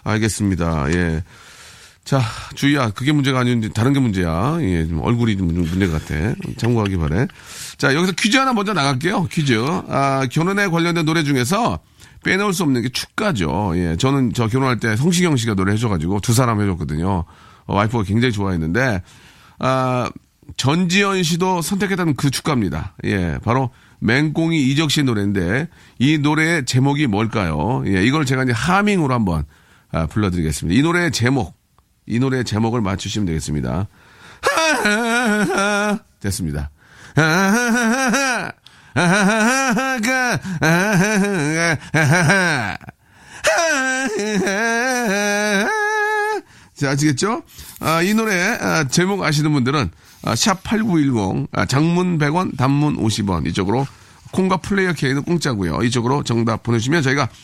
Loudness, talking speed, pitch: -18 LUFS, 275 characters per minute, 135 Hz